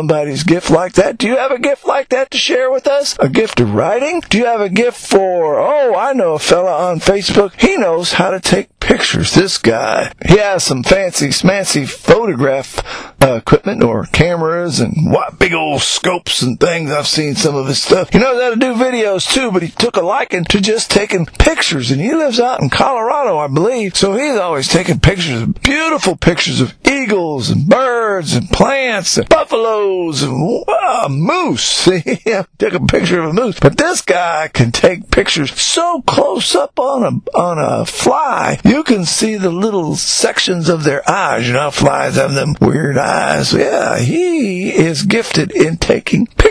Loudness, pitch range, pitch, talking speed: -13 LUFS, 170-250 Hz, 195 Hz, 195 wpm